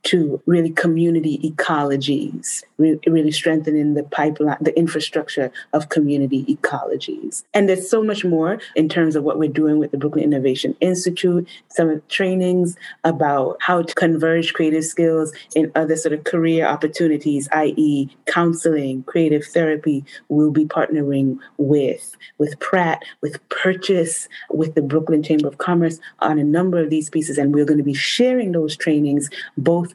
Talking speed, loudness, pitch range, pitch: 155 wpm, -19 LUFS, 150-170 Hz, 155 Hz